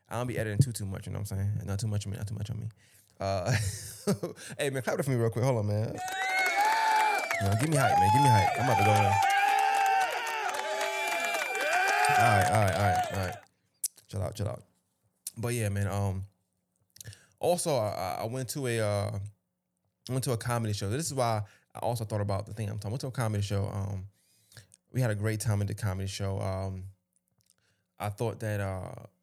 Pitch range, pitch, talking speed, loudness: 100-125 Hz, 110 Hz, 220 wpm, -29 LUFS